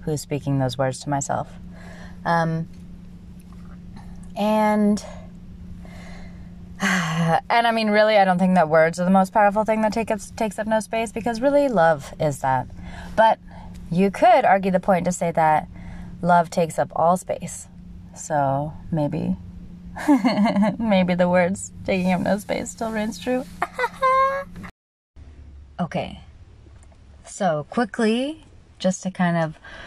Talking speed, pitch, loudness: 135 wpm, 165 Hz, -21 LUFS